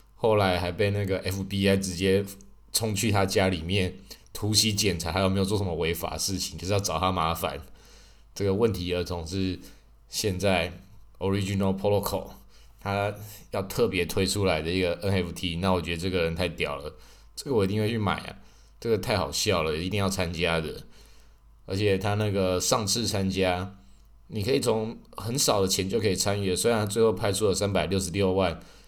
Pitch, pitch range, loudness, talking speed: 95 Hz, 90-100 Hz, -27 LUFS, 300 characters per minute